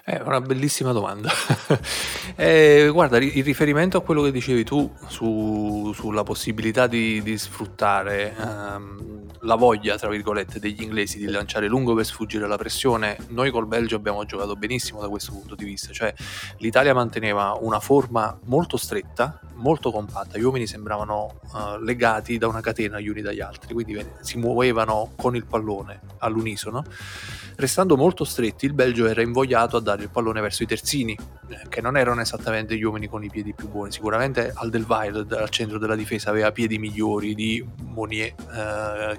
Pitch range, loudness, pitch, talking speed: 105-120 Hz, -23 LUFS, 110 Hz, 170 wpm